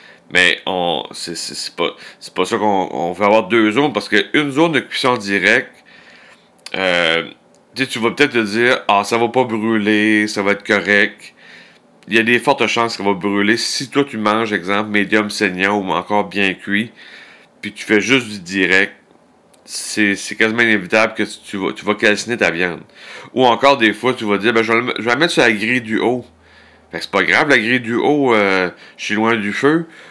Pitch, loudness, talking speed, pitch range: 110 Hz, -15 LUFS, 215 wpm, 105-120 Hz